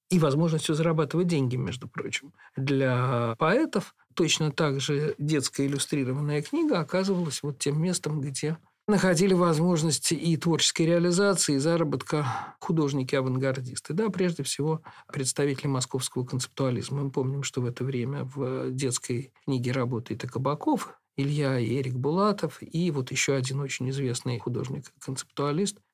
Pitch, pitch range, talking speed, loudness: 145 Hz, 130-165 Hz, 130 wpm, -27 LUFS